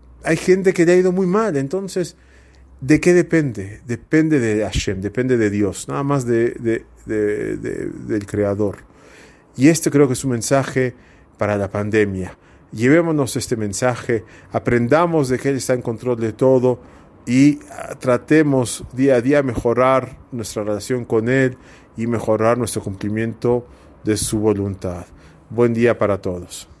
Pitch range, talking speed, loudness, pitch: 105-135 Hz, 155 wpm, -19 LUFS, 120 Hz